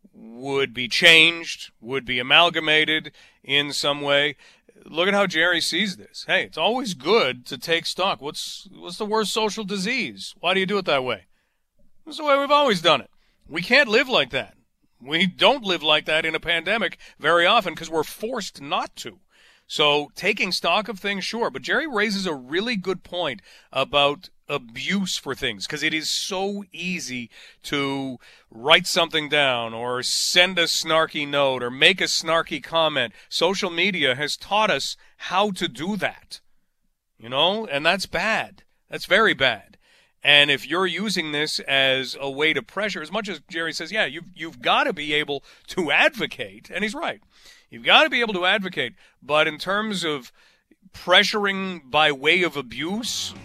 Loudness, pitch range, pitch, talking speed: -21 LUFS, 145-195 Hz, 165 Hz, 175 wpm